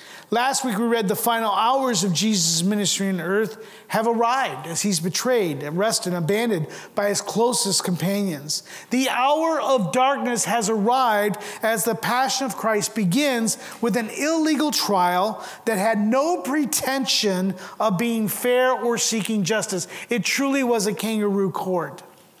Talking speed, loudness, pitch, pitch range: 150 wpm, -22 LUFS, 220 Hz, 195-250 Hz